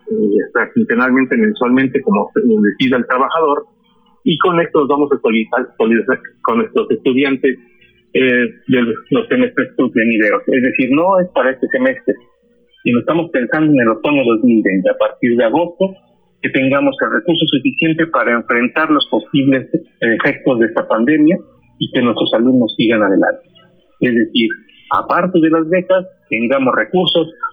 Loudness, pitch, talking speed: -14 LUFS, 170 Hz, 150 wpm